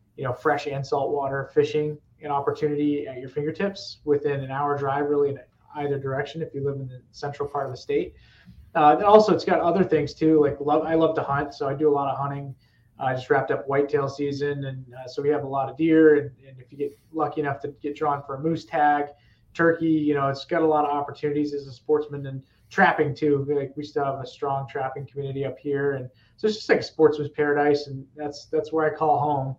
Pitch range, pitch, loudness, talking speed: 135-150 Hz, 145 Hz, -24 LUFS, 245 wpm